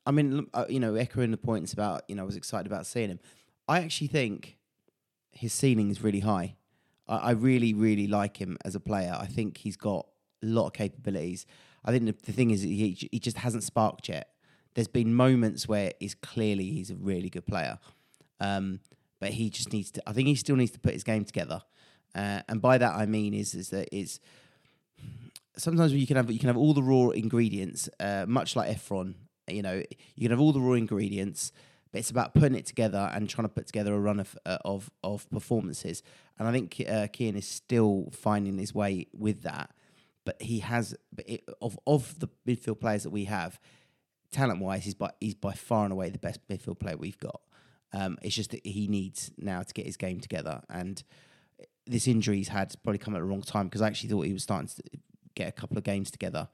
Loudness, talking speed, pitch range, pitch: -30 LUFS, 220 wpm, 100-125 Hz, 110 Hz